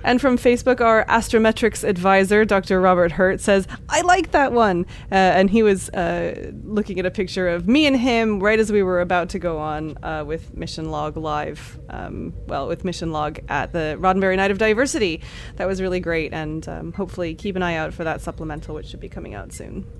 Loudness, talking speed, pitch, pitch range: -20 LUFS, 215 wpm, 185 Hz, 165-220 Hz